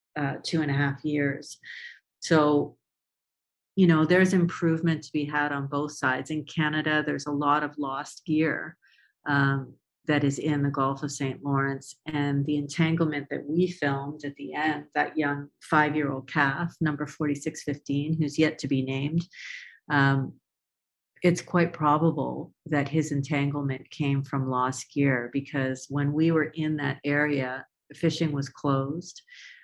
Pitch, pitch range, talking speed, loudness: 145 Hz, 140-155 Hz, 155 wpm, -27 LUFS